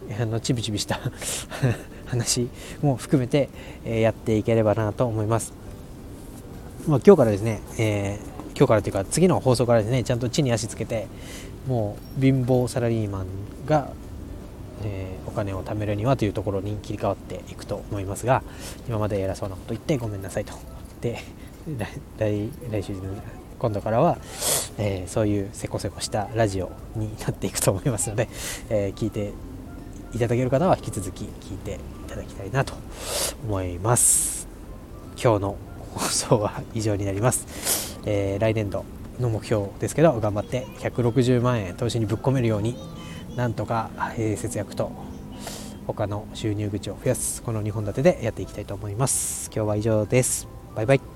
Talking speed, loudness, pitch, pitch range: 330 characters per minute, -25 LUFS, 105 Hz, 100-120 Hz